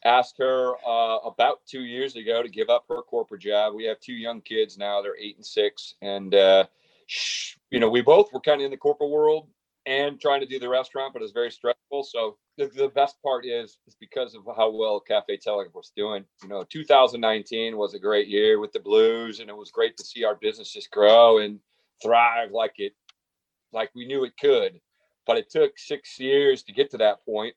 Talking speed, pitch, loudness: 220 wpm, 155 Hz, -23 LUFS